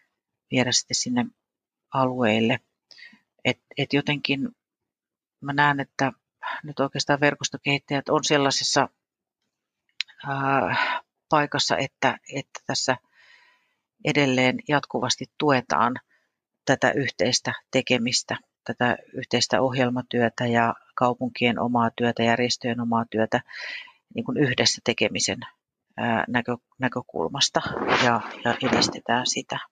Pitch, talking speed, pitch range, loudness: 130 Hz, 95 wpm, 120-145 Hz, -24 LUFS